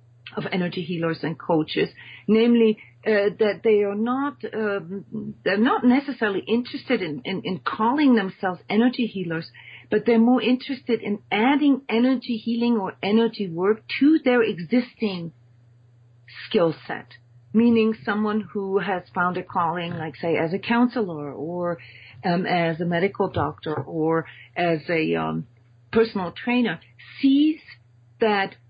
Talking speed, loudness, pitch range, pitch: 135 wpm, -23 LUFS, 160-230 Hz, 195 Hz